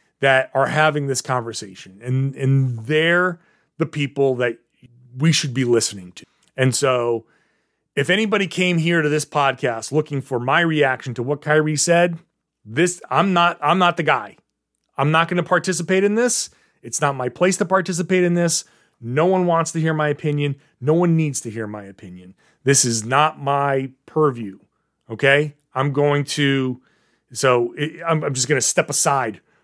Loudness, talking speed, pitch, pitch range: -19 LUFS, 175 wpm, 145 Hz, 130-165 Hz